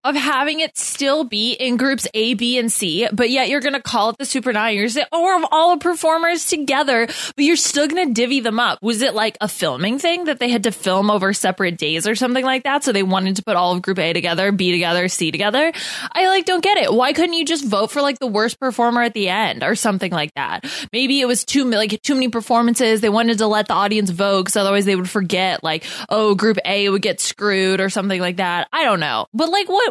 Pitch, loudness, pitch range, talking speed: 230 Hz, -17 LUFS, 200-275 Hz, 255 wpm